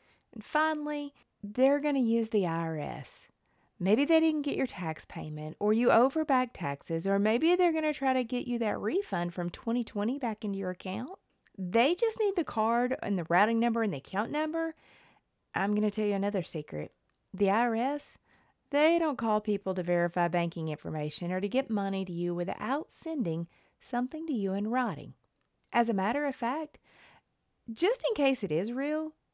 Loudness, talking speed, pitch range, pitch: -30 LUFS, 185 wpm, 190-280 Hz, 230 Hz